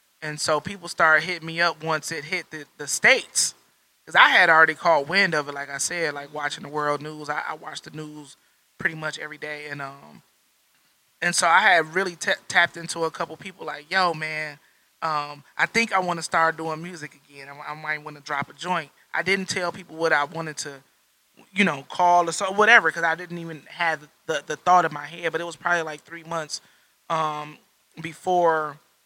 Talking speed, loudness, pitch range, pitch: 220 wpm, -22 LUFS, 150-175 Hz, 160 Hz